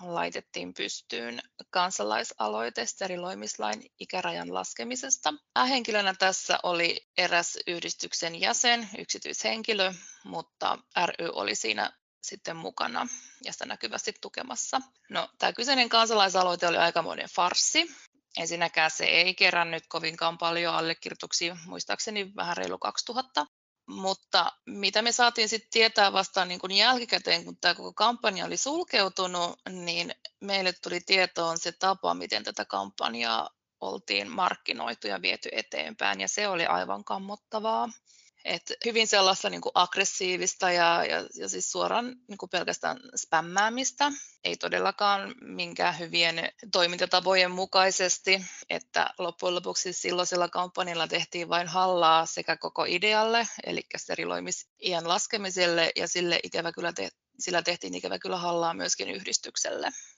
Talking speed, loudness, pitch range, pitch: 120 wpm, -27 LUFS, 170-210 Hz, 185 Hz